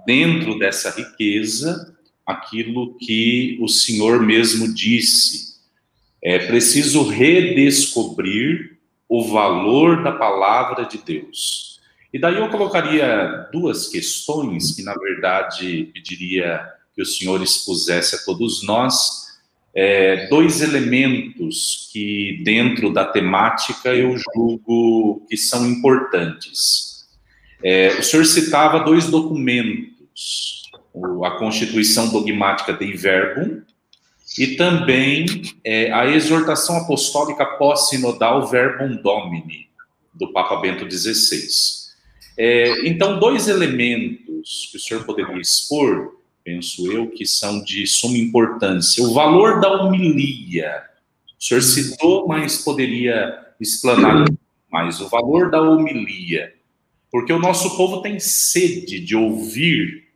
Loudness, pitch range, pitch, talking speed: -17 LUFS, 110-160 Hz, 125 Hz, 110 wpm